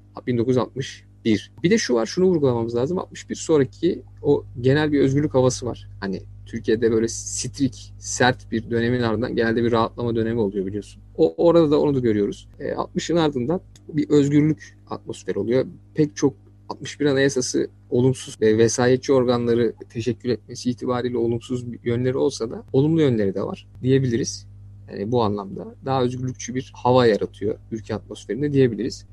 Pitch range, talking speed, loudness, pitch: 105-130 Hz, 155 wpm, -22 LUFS, 120 Hz